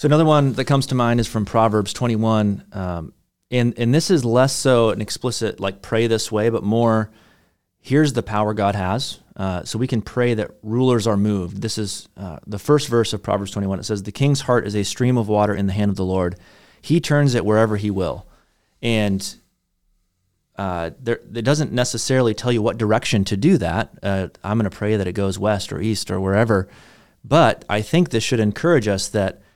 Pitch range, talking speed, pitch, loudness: 100-120 Hz, 215 wpm, 110 Hz, -20 LUFS